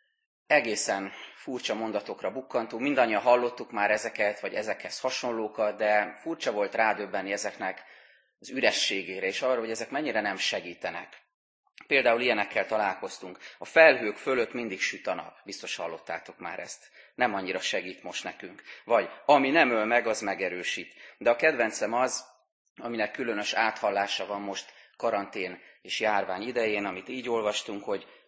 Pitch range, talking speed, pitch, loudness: 100-120 Hz, 145 wpm, 110 Hz, -28 LUFS